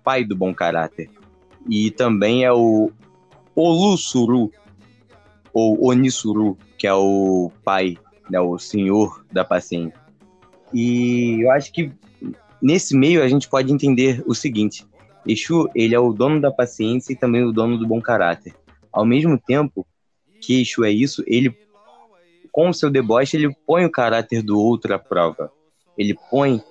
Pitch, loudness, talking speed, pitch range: 120 Hz, -18 LUFS, 155 wpm, 105-135 Hz